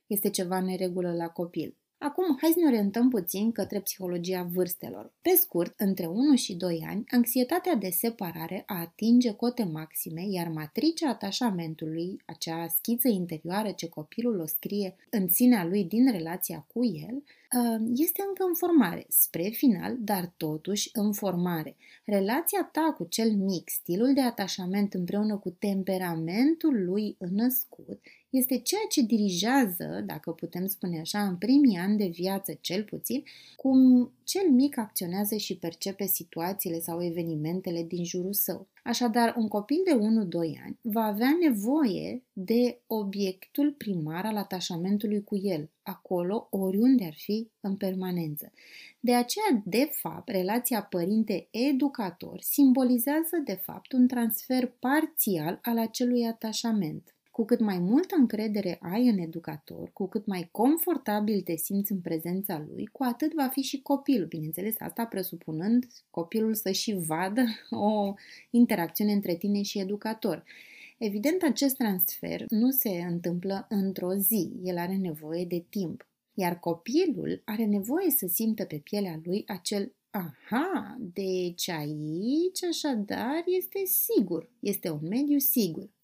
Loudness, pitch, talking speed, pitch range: -28 LUFS, 205 Hz, 140 wpm, 180-245 Hz